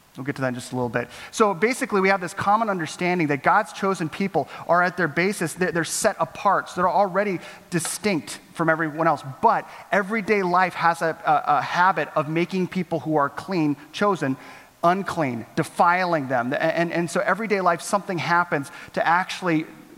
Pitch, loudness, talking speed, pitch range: 175 Hz, -23 LUFS, 190 wpm, 160-195 Hz